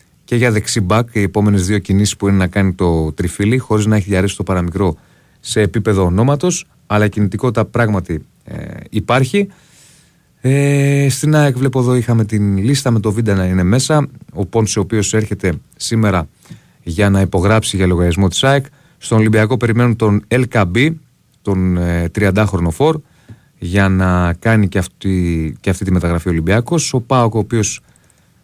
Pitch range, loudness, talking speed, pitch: 95-125 Hz, -15 LUFS, 165 wpm, 110 Hz